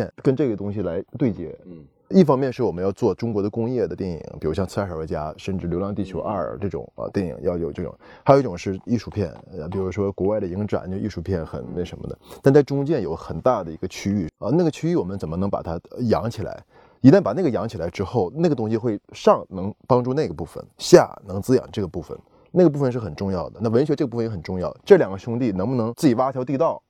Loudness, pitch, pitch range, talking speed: -22 LUFS, 100 Hz, 95-125 Hz, 375 characters per minute